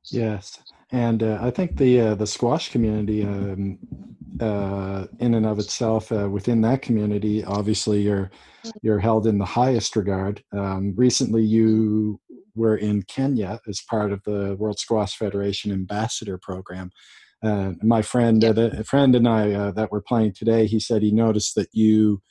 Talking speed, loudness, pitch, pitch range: 170 wpm, -22 LUFS, 110 Hz, 100-115 Hz